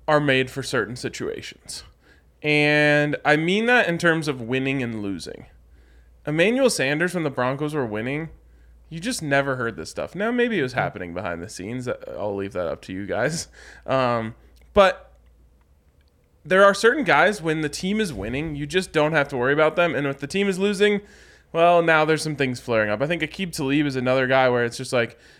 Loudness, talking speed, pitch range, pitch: -22 LUFS, 205 wpm, 115-165 Hz, 140 Hz